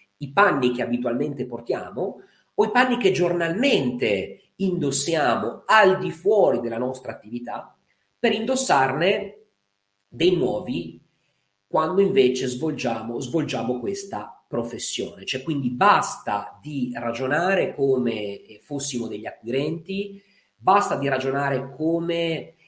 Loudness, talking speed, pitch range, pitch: -23 LUFS, 105 wpm, 120-180 Hz, 140 Hz